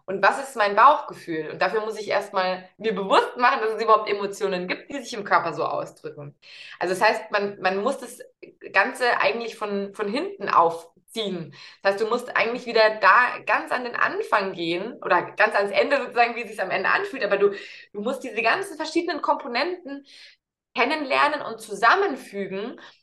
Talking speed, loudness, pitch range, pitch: 185 wpm, -23 LUFS, 195-250 Hz, 215 Hz